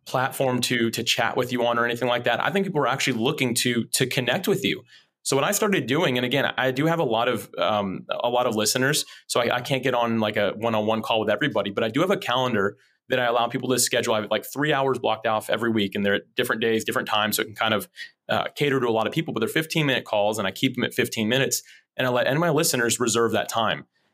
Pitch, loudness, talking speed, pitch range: 125 Hz, -23 LUFS, 285 wpm, 115-135 Hz